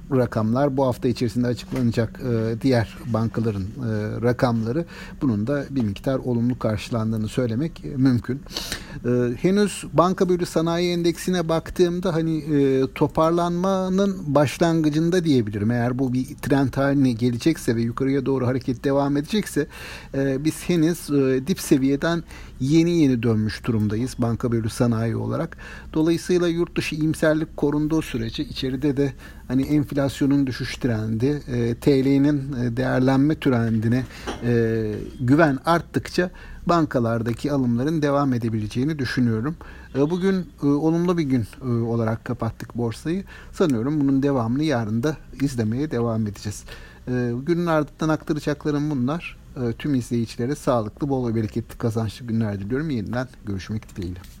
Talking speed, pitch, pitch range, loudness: 120 wpm, 135 Hz, 120-155 Hz, -23 LUFS